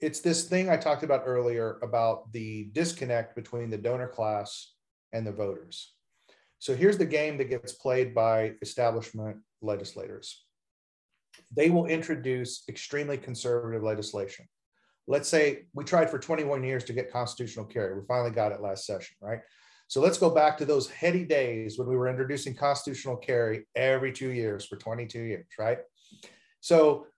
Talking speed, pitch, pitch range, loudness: 160 wpm, 125 Hz, 115-145 Hz, -29 LUFS